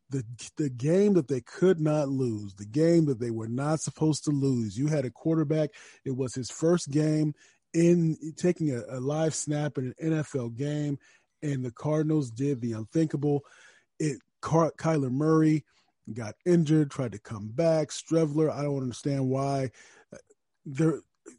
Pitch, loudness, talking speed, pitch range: 145 Hz, -28 LUFS, 160 wpm, 130-160 Hz